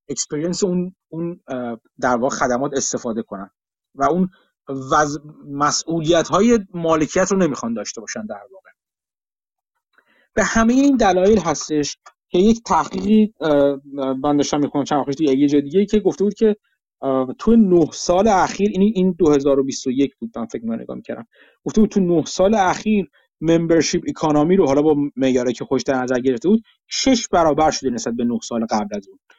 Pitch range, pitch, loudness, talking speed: 135-195 Hz, 155 Hz, -18 LUFS, 165 wpm